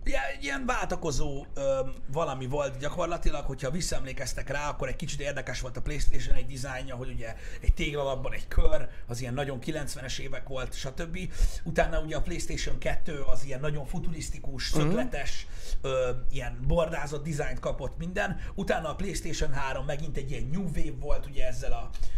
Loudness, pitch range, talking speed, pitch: -33 LUFS, 130-160 Hz, 165 wpm, 145 Hz